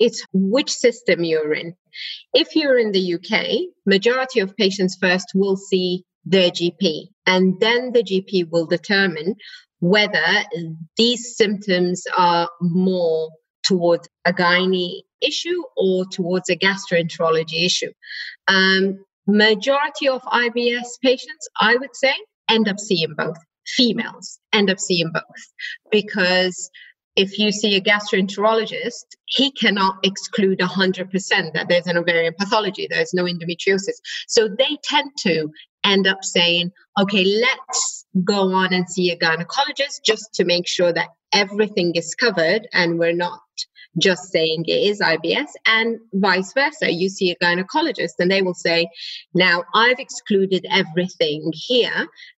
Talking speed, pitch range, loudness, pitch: 135 wpm, 180-235 Hz, -19 LUFS, 195 Hz